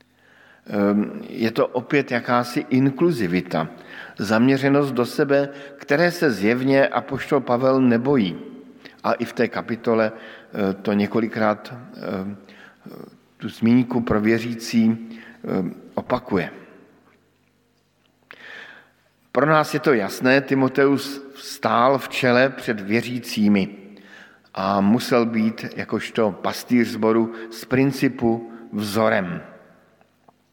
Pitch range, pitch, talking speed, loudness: 110-135 Hz, 120 Hz, 90 wpm, -21 LUFS